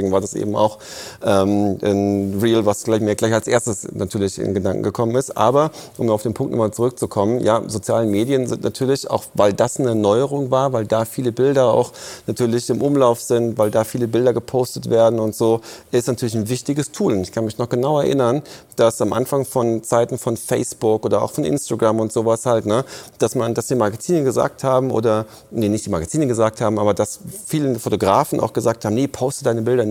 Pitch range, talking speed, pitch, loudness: 110-130 Hz, 210 wpm, 115 Hz, -19 LUFS